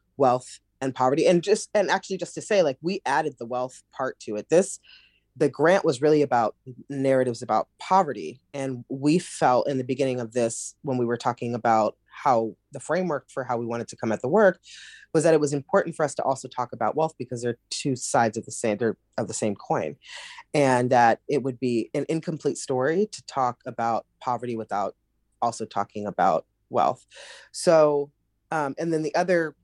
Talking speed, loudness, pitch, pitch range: 200 wpm, -25 LUFS, 130 Hz, 120-150 Hz